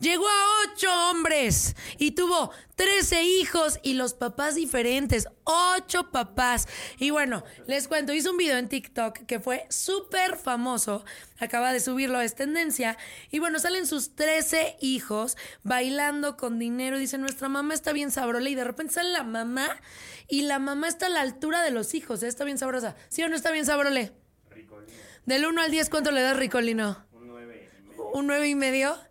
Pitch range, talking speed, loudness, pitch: 250-320 Hz, 180 wpm, -26 LUFS, 280 Hz